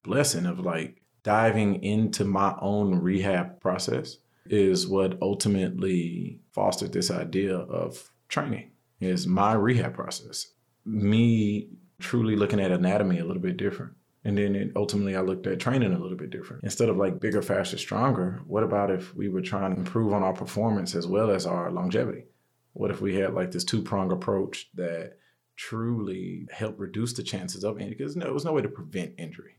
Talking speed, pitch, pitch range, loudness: 185 wpm, 100 Hz, 95-110 Hz, -27 LUFS